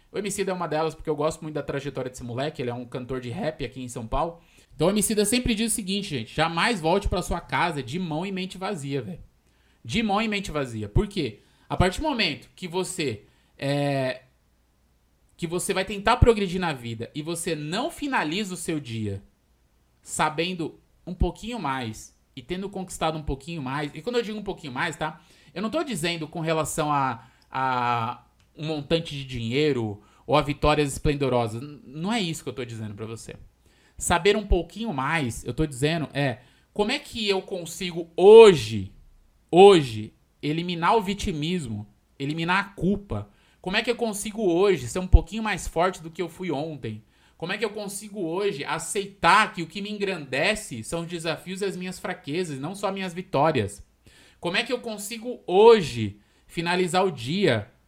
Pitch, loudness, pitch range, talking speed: 165 Hz, -25 LUFS, 130-195 Hz, 190 wpm